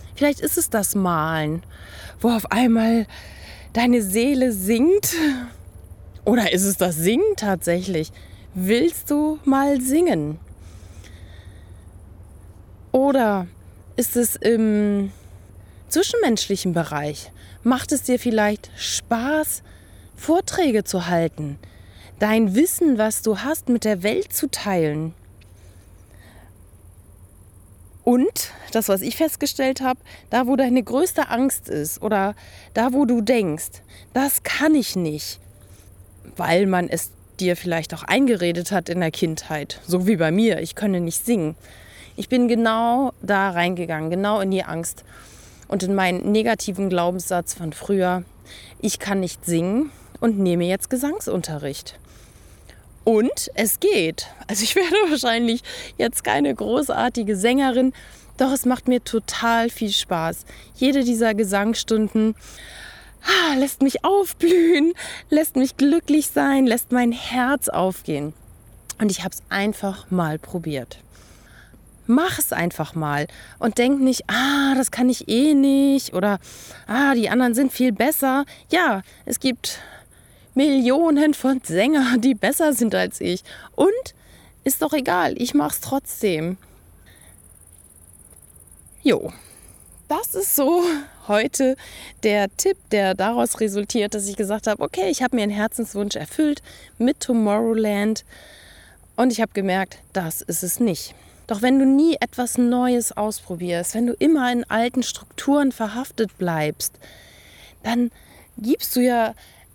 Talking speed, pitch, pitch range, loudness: 130 wpm, 215 Hz, 165-255 Hz, -21 LUFS